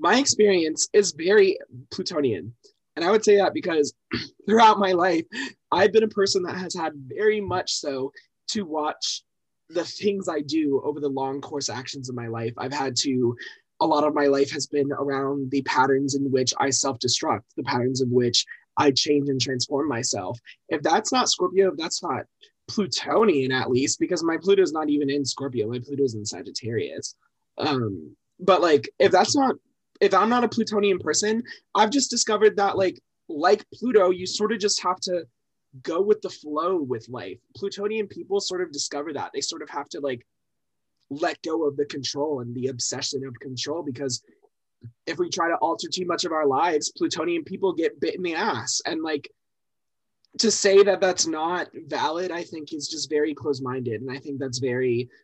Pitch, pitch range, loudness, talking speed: 155 Hz, 135-205 Hz, -24 LUFS, 190 wpm